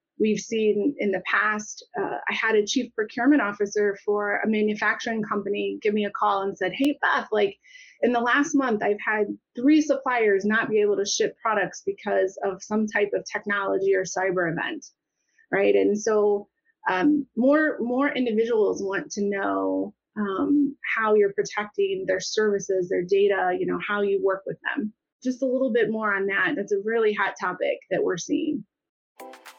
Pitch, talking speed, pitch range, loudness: 210 Hz, 180 wpm, 200-245 Hz, -24 LUFS